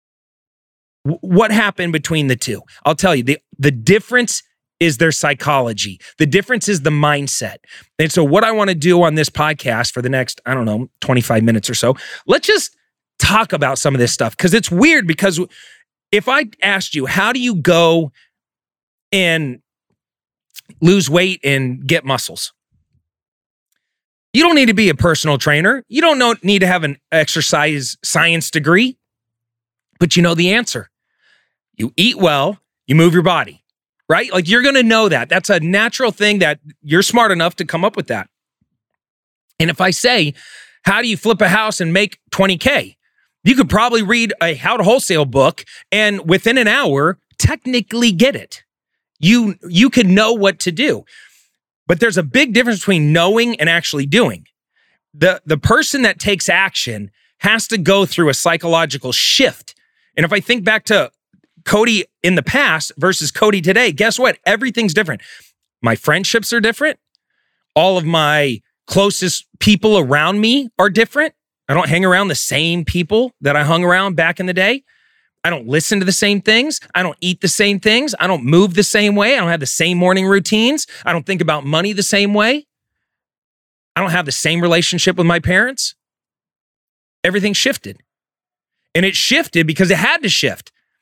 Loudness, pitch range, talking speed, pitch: -14 LUFS, 155-215 Hz, 180 wpm, 185 Hz